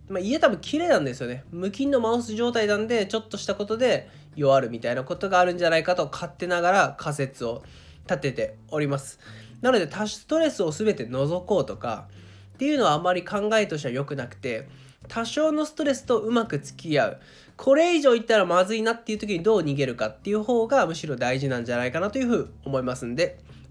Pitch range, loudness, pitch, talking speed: 135-225 Hz, -25 LUFS, 180 Hz, 440 characters per minute